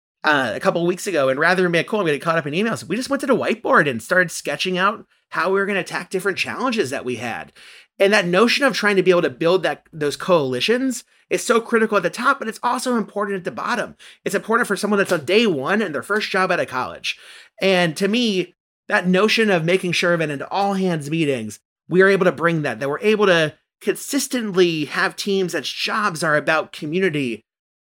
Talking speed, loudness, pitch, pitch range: 240 wpm, -19 LUFS, 185 Hz, 165-210 Hz